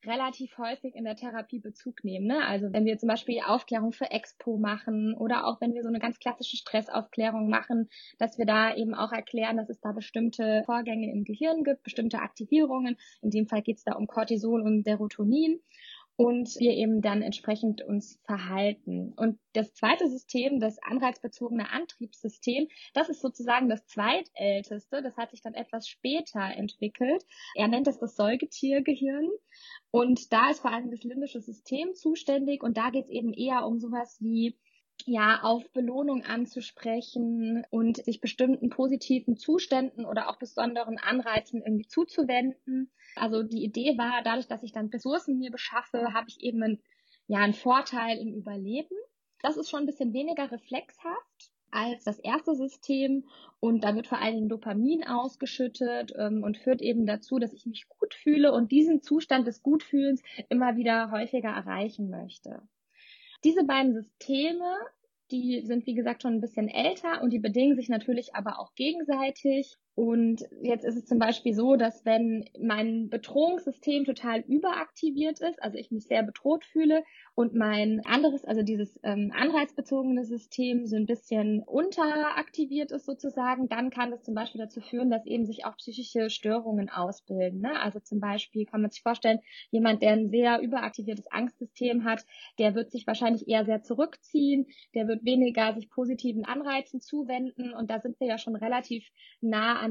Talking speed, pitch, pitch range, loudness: 170 wpm, 240 Hz, 225-270 Hz, -29 LUFS